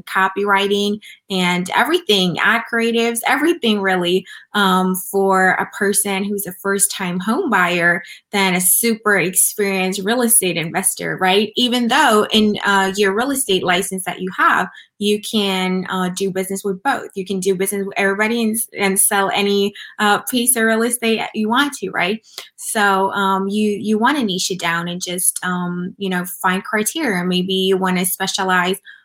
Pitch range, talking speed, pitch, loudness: 185-215 Hz, 170 wpm, 195 Hz, -17 LUFS